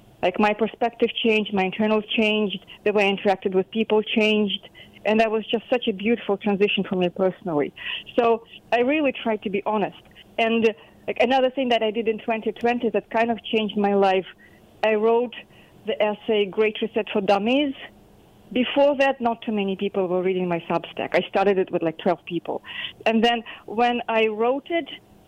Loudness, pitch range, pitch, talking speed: -23 LUFS, 195-230 Hz, 215 Hz, 185 wpm